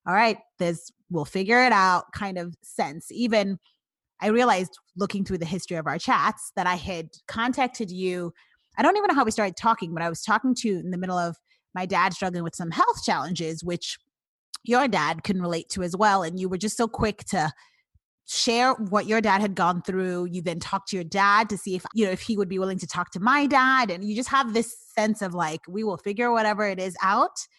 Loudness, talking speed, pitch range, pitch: -25 LUFS, 235 wpm, 180-230 Hz, 195 Hz